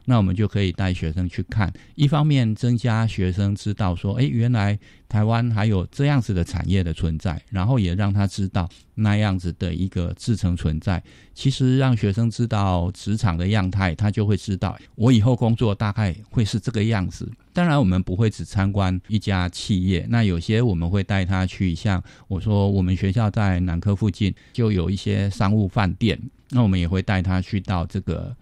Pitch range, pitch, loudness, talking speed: 95-115 Hz, 100 Hz, -22 LUFS, 290 characters per minute